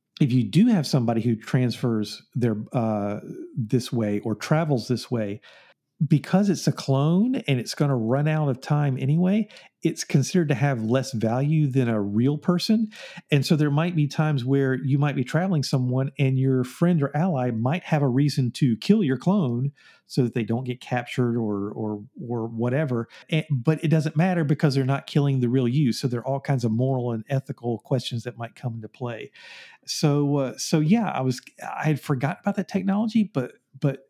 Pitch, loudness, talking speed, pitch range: 135 Hz, -24 LUFS, 200 wpm, 125-155 Hz